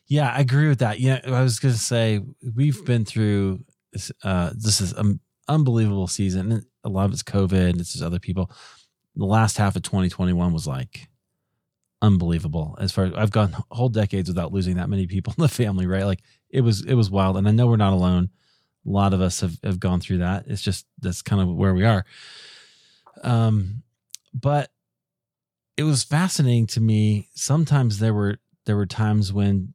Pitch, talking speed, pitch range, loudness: 105 Hz, 200 wpm, 95-120 Hz, -22 LUFS